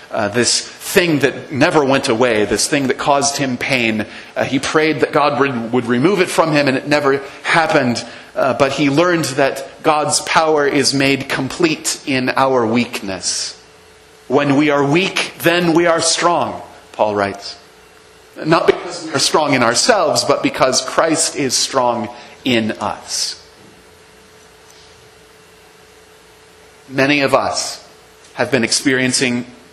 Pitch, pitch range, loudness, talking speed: 140 Hz, 125-150 Hz, -15 LUFS, 145 wpm